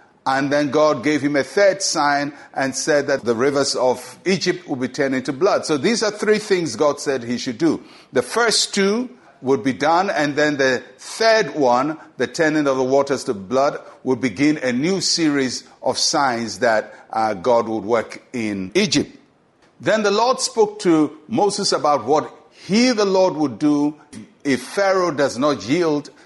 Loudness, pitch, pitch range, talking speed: -19 LUFS, 150 Hz, 135-190 Hz, 185 wpm